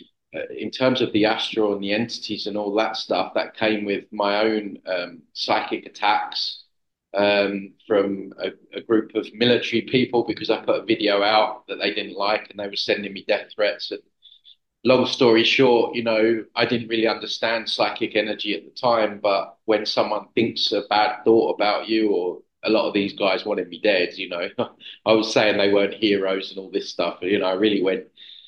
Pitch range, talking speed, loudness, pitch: 100-115 Hz, 200 wpm, -22 LUFS, 110 Hz